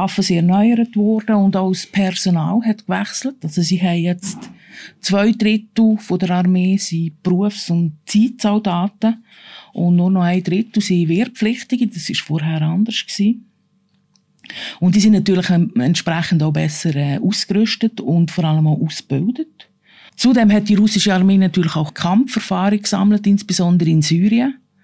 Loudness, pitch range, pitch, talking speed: -16 LUFS, 175-215 Hz, 195 Hz, 145 wpm